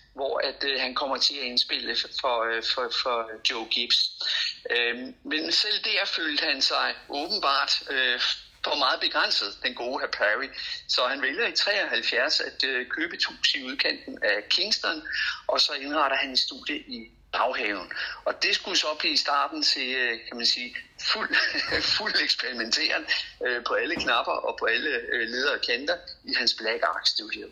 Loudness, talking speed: -25 LUFS, 180 wpm